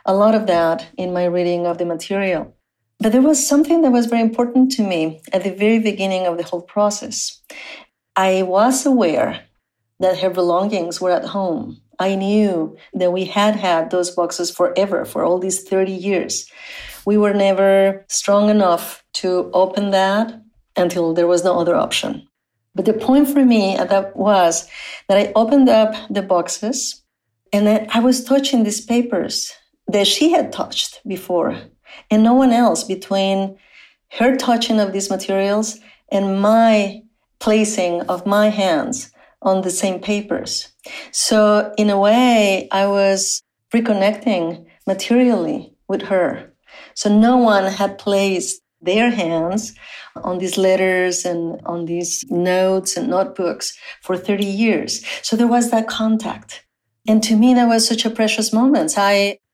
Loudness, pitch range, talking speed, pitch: -17 LUFS, 185-225 Hz, 155 wpm, 200 Hz